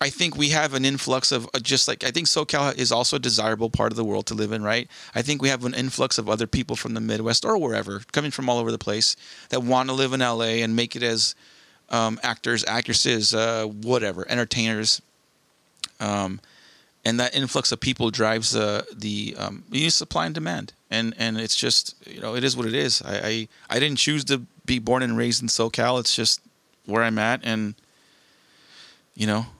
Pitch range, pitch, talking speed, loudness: 110-130 Hz, 115 Hz, 215 wpm, -23 LUFS